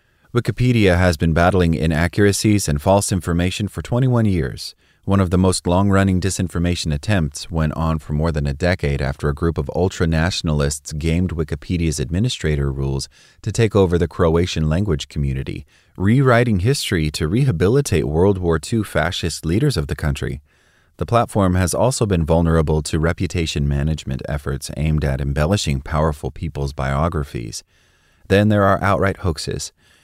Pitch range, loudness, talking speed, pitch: 75-95 Hz, -19 LUFS, 150 wpm, 85 Hz